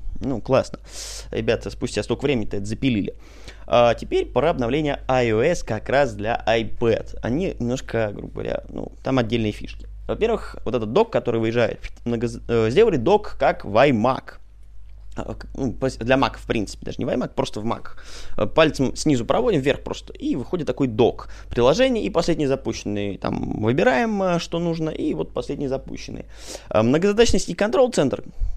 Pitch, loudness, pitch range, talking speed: 120 Hz, -22 LUFS, 110-145 Hz, 155 wpm